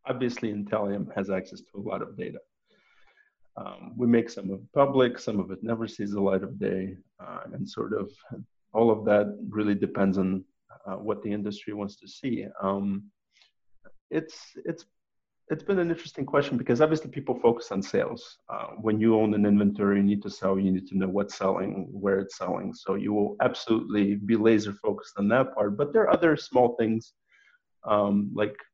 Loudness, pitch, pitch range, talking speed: -27 LUFS, 105 Hz, 100-115 Hz, 195 wpm